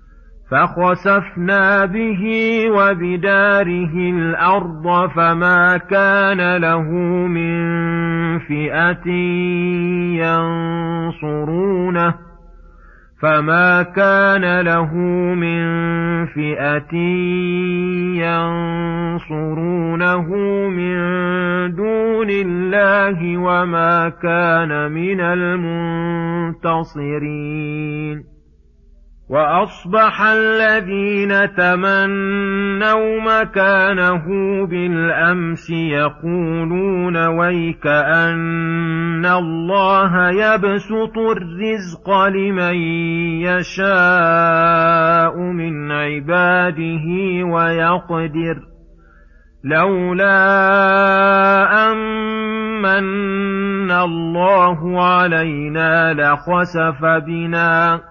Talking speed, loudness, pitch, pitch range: 45 wpm, -16 LUFS, 175 Hz, 165-195 Hz